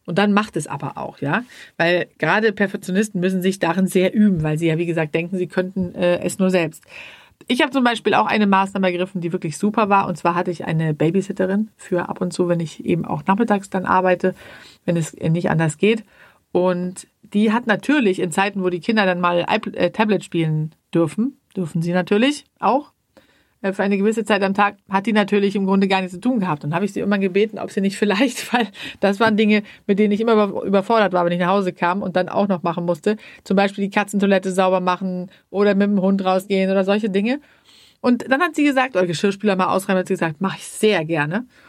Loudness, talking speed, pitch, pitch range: -19 LUFS, 225 wpm, 195 Hz, 180-210 Hz